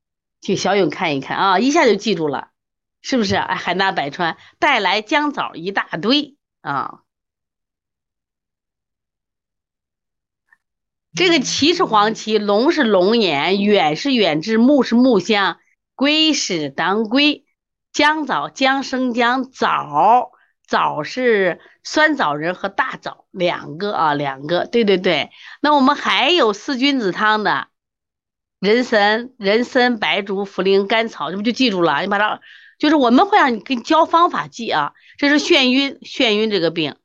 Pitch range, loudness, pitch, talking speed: 195-275 Hz, -17 LUFS, 225 Hz, 205 characters per minute